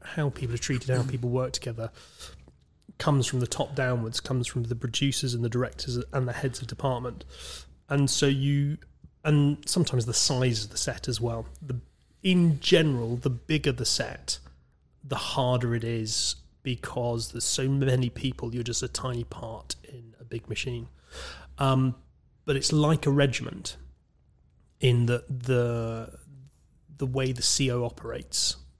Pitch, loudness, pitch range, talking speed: 125 Hz, -28 LUFS, 115-135 Hz, 160 wpm